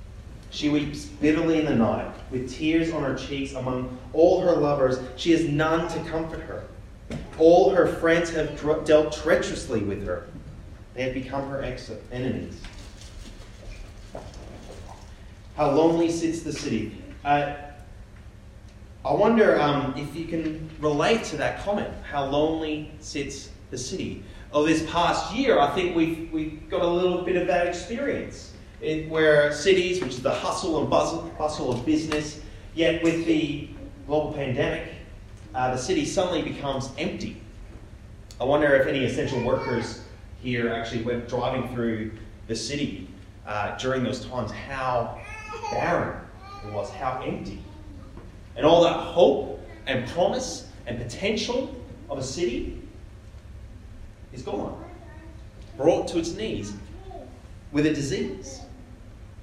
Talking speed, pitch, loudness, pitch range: 135 wpm, 130 Hz, -25 LUFS, 105-155 Hz